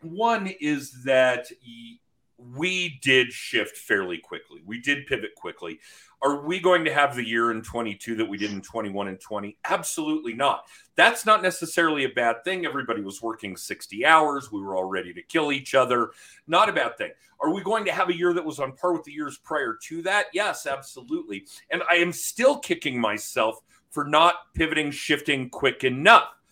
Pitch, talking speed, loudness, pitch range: 145 Hz, 190 wpm, -24 LUFS, 120-180 Hz